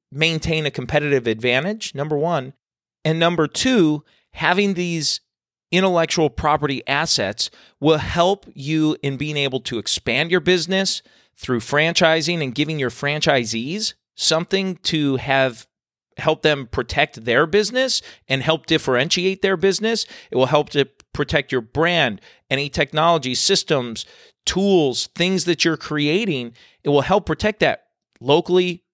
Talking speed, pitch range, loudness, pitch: 135 wpm, 140-180 Hz, -19 LUFS, 155 Hz